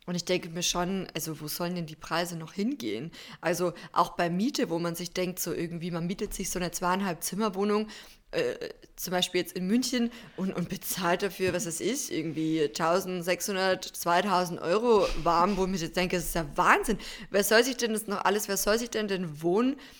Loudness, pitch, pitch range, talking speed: -29 LUFS, 180 Hz, 175-210 Hz, 210 wpm